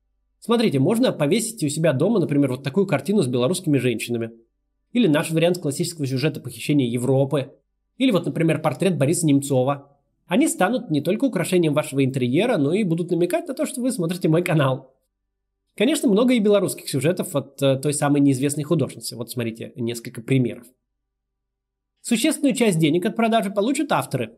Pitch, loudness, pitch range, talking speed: 150 Hz, -21 LUFS, 130-190 Hz, 160 wpm